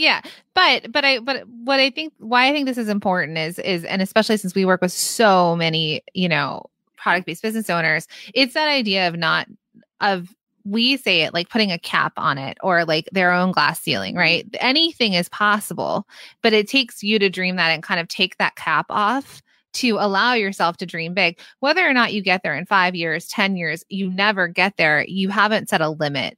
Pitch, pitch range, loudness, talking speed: 195 Hz, 175-230 Hz, -19 LUFS, 215 wpm